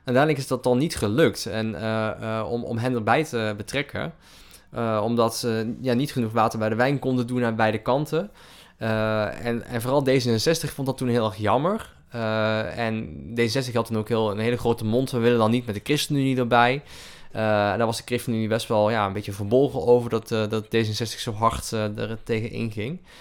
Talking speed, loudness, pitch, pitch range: 215 wpm, -24 LUFS, 115 Hz, 110-125 Hz